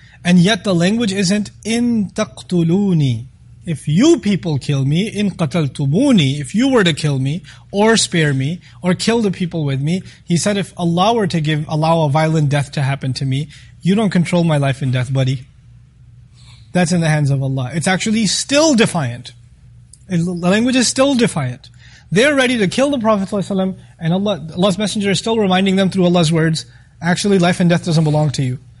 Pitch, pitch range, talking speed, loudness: 170 Hz, 135-200 Hz, 195 wpm, -16 LUFS